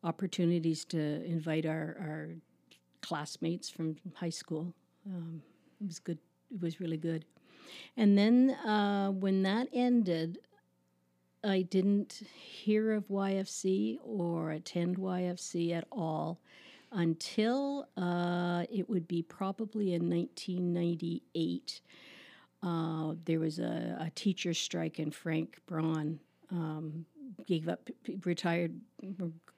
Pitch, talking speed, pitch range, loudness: 175 Hz, 115 wpm, 160-195 Hz, -34 LUFS